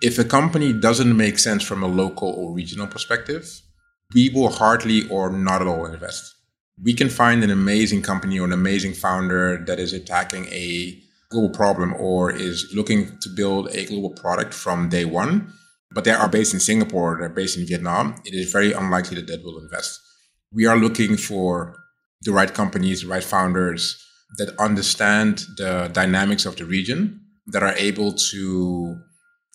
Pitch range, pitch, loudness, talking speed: 90-115 Hz, 100 Hz, -20 LUFS, 175 wpm